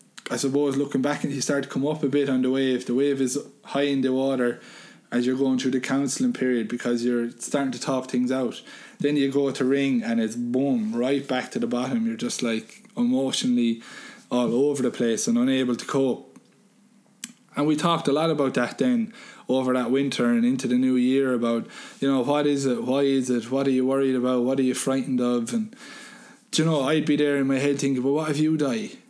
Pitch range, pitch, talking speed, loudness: 125-150 Hz, 135 Hz, 230 wpm, -24 LUFS